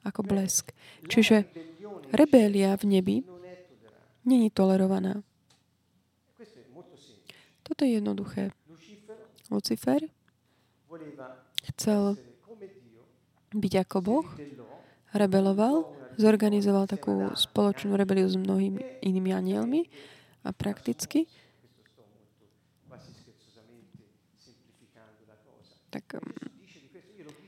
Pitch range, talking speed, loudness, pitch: 130-205 Hz, 60 wpm, -27 LUFS, 190 Hz